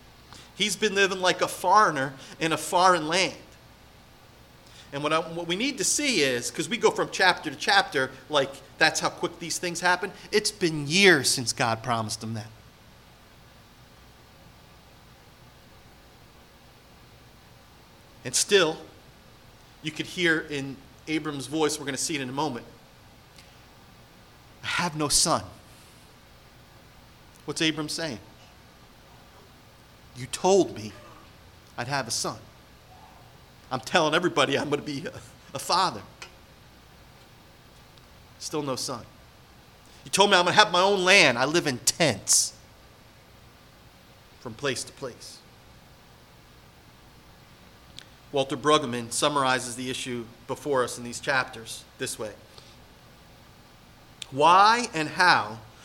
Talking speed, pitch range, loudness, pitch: 125 wpm, 115-170 Hz, -24 LUFS, 140 Hz